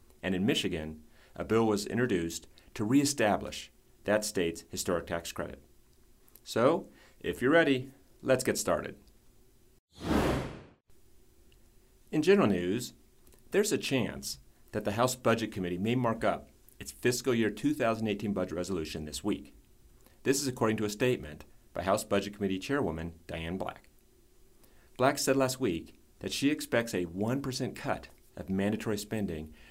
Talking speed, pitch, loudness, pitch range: 140 wpm, 105 Hz, -31 LUFS, 90-125 Hz